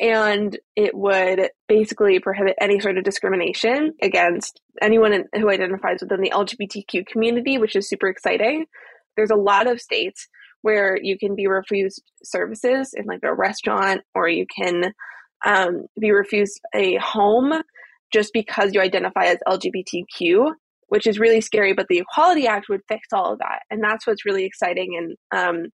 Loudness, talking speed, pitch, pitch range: -20 LUFS, 165 wpm, 205 Hz, 190-225 Hz